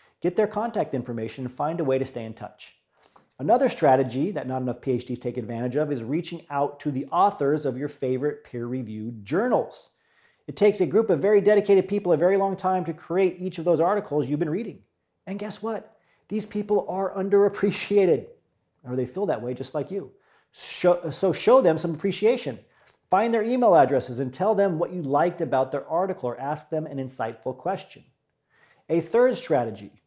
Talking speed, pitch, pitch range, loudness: 190 wpm, 165 Hz, 130-195 Hz, -24 LUFS